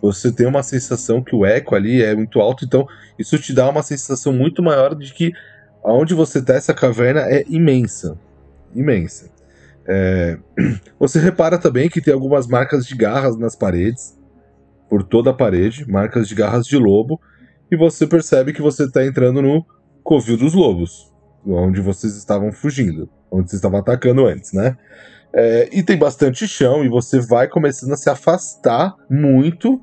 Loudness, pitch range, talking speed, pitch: -16 LUFS, 105-145 Hz, 170 wpm, 130 Hz